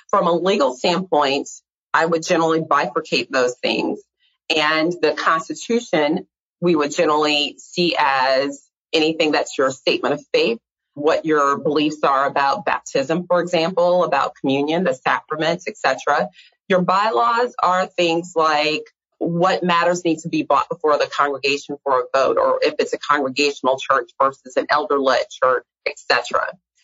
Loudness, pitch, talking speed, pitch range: -19 LUFS, 160 Hz, 150 wpm, 145-180 Hz